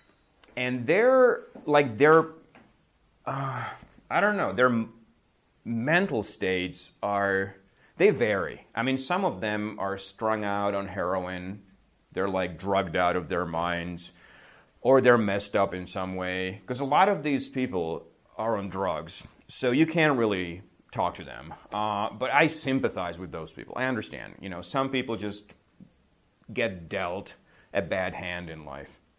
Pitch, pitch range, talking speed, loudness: 100 Hz, 95-130 Hz, 155 wpm, -27 LUFS